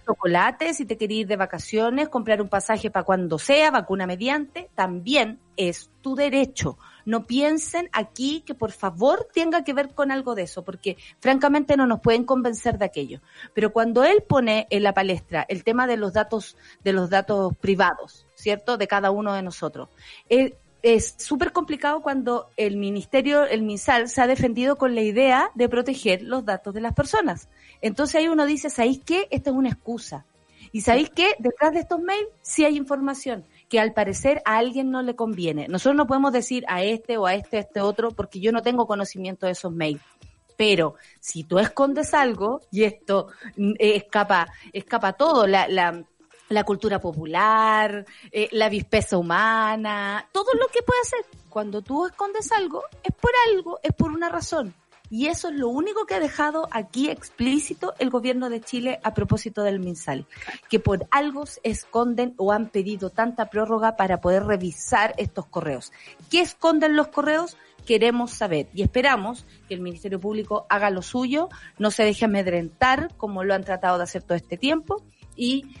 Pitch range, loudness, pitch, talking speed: 200-275 Hz, -23 LUFS, 225 Hz, 180 wpm